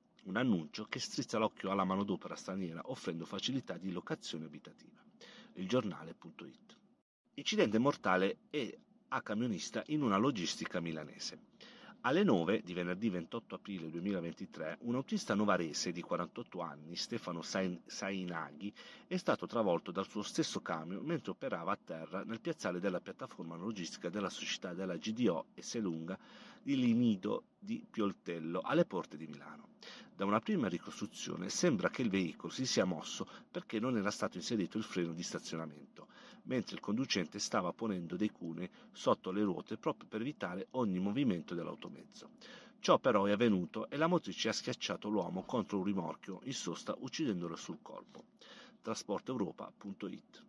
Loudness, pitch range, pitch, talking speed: -38 LUFS, 85-115 Hz, 95 Hz, 145 wpm